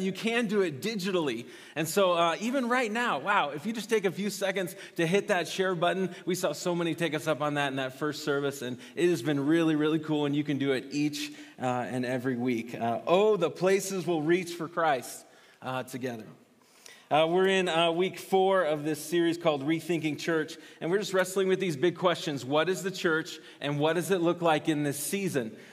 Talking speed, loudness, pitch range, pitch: 225 wpm, -29 LUFS, 150-185 Hz, 165 Hz